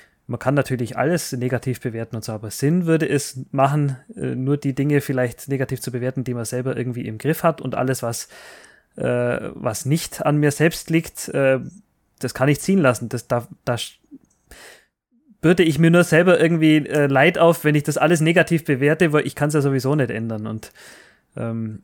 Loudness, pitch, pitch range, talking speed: -20 LUFS, 140 Hz, 125-155 Hz, 195 wpm